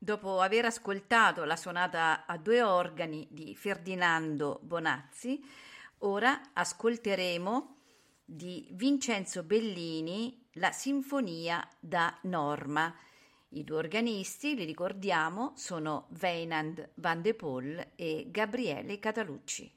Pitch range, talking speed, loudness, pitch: 165-230 Hz, 100 wpm, -33 LUFS, 185 Hz